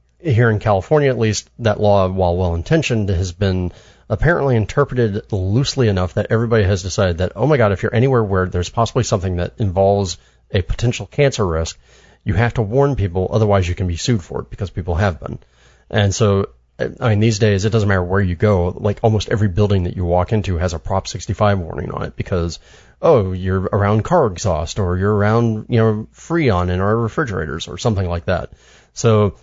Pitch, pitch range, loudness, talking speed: 105 Hz, 90-115 Hz, -18 LUFS, 200 wpm